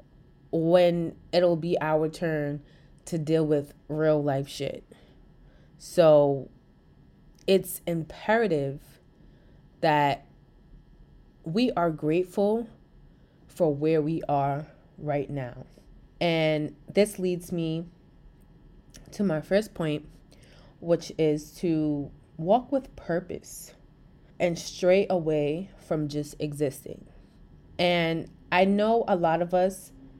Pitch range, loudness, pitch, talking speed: 150-180 Hz, -27 LUFS, 160 Hz, 100 wpm